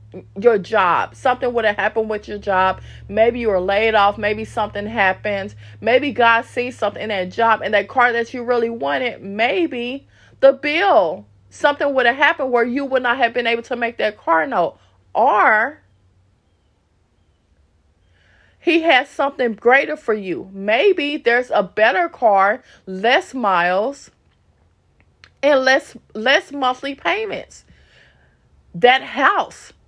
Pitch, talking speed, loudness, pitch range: 225 Hz, 145 wpm, -17 LUFS, 190-255 Hz